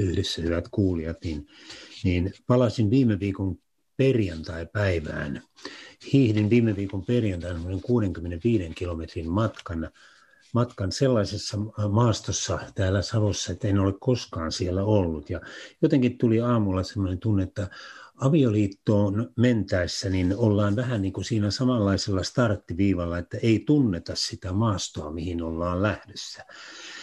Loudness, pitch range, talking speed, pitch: -25 LUFS, 90-115 Hz, 115 wpm, 100 Hz